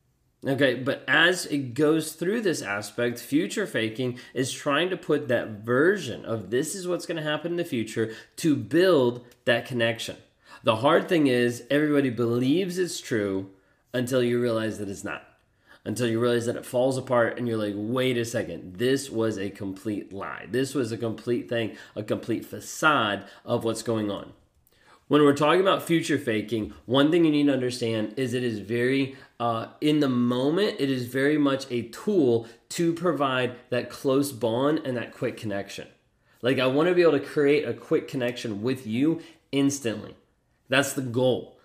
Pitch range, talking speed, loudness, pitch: 115-140 Hz, 180 wpm, -26 LUFS, 125 Hz